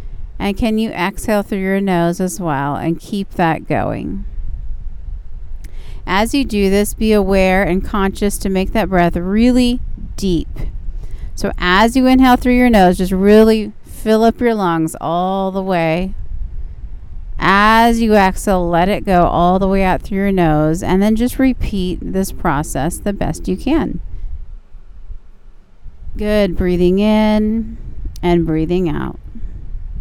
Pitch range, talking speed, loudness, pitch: 155-210 Hz, 145 wpm, -15 LUFS, 185 Hz